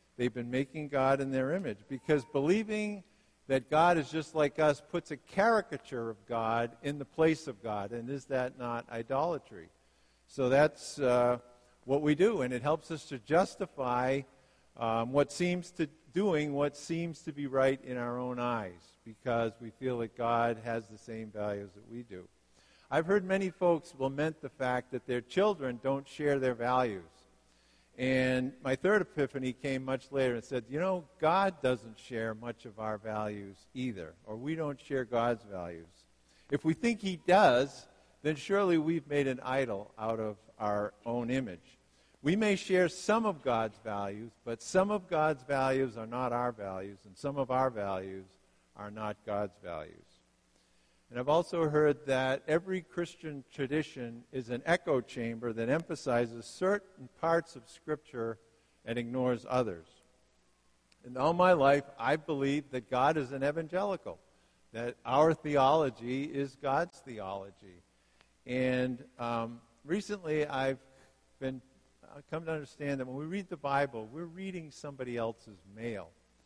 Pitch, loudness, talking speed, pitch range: 130 Hz, -33 LUFS, 160 wpm, 115-150 Hz